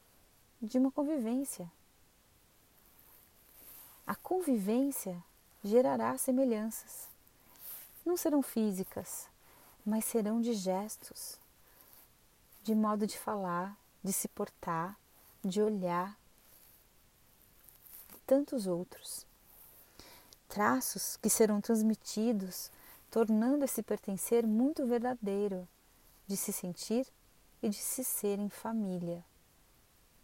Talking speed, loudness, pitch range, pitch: 85 wpm, -34 LUFS, 195-245 Hz, 220 Hz